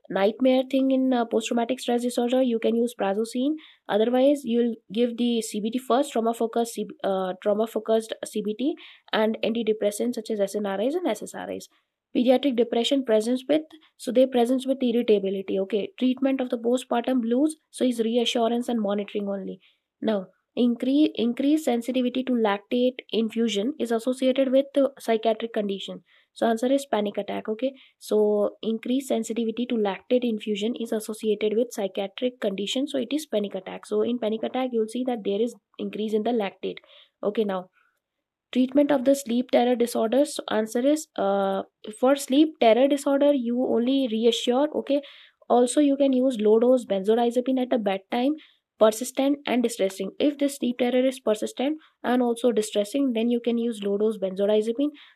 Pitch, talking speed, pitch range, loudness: 240 Hz, 160 wpm, 215-260 Hz, -25 LUFS